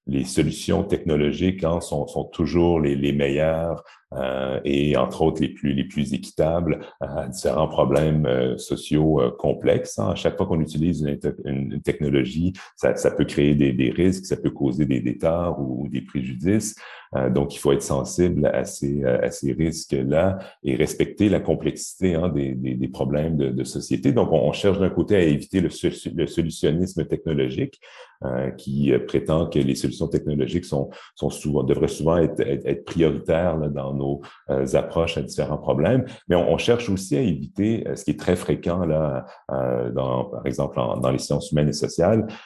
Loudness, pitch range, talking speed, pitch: -23 LUFS, 70-85 Hz, 185 wpm, 75 Hz